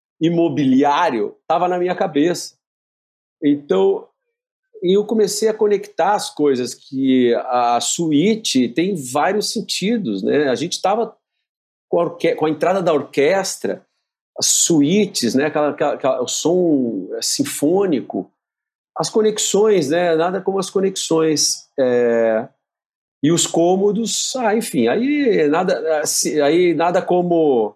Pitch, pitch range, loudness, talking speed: 175 Hz, 145-210 Hz, -17 LUFS, 120 wpm